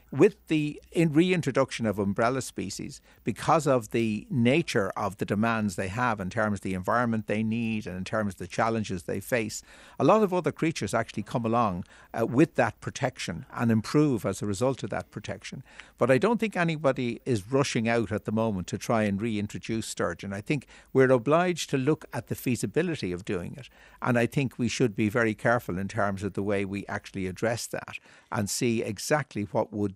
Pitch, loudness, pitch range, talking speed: 115 Hz, -28 LUFS, 105-130 Hz, 200 wpm